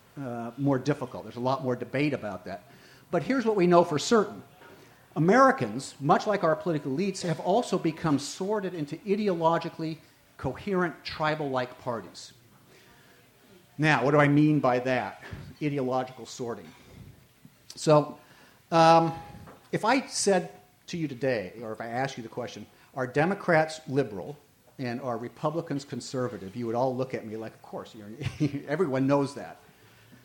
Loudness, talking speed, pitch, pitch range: -27 LUFS, 155 wpm, 145 Hz, 125-165 Hz